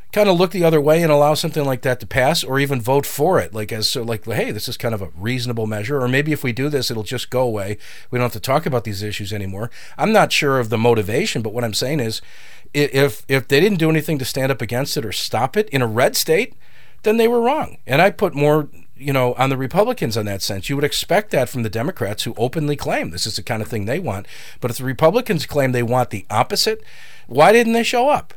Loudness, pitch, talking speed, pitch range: -19 LUFS, 130 Hz, 270 wpm, 115-155 Hz